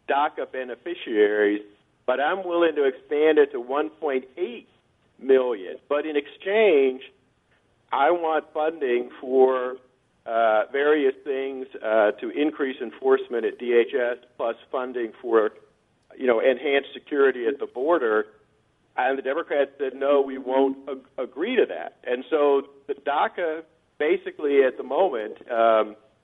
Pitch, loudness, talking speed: 145 Hz, -24 LUFS, 130 wpm